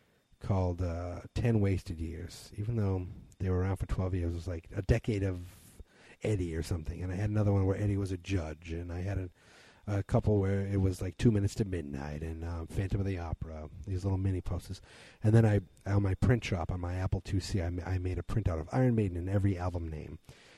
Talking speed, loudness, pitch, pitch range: 235 wpm, -33 LUFS, 95 Hz, 90-100 Hz